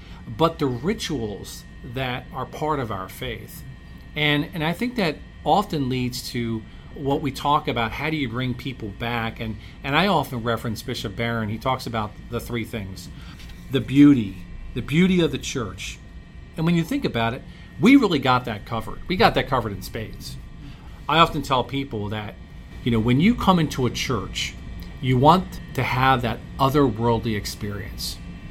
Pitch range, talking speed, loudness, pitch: 110-145 Hz, 175 wpm, -23 LUFS, 125 Hz